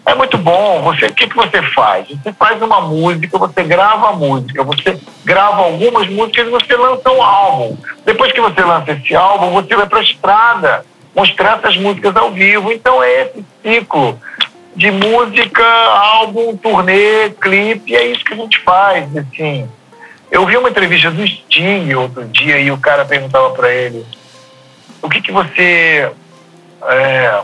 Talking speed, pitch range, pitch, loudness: 170 wpm, 150-230 Hz, 200 Hz, -10 LUFS